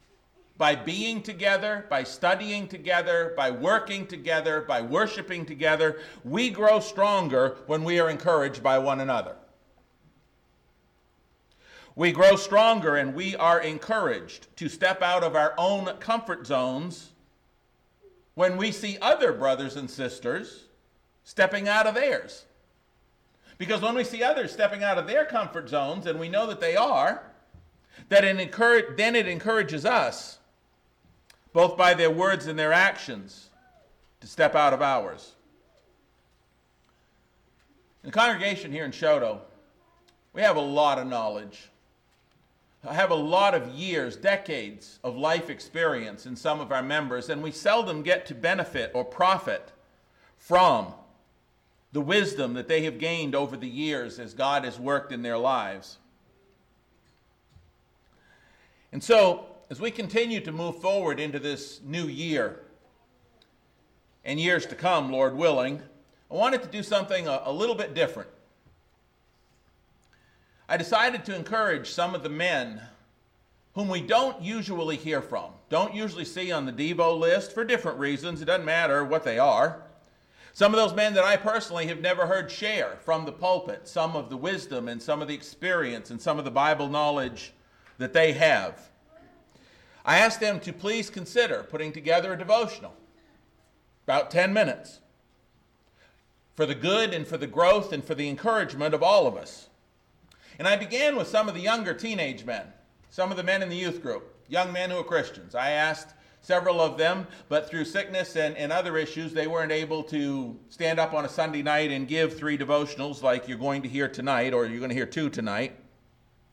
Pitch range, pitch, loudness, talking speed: 140-195 Hz, 160 Hz, -26 LUFS, 165 wpm